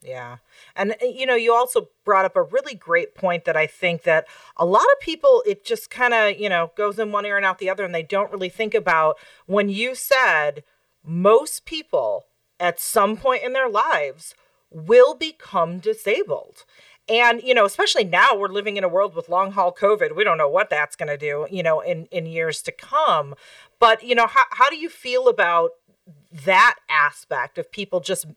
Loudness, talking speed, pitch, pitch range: -20 LUFS, 205 wpm, 205 Hz, 170-250 Hz